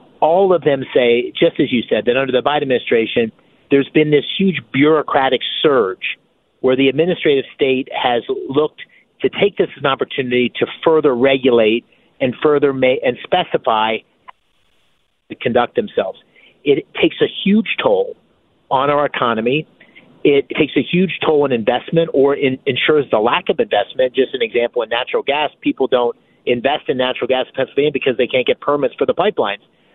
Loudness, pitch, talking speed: -16 LUFS, 155 Hz, 170 wpm